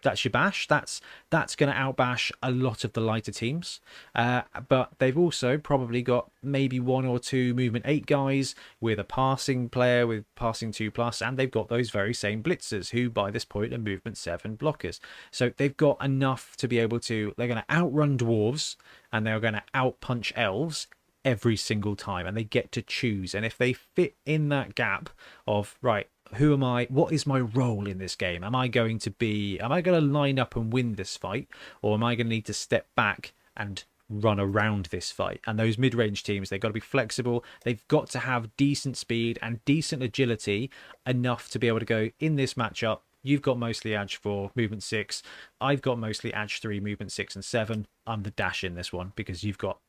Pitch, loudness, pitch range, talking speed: 120 Hz, -28 LUFS, 110-130 Hz, 210 wpm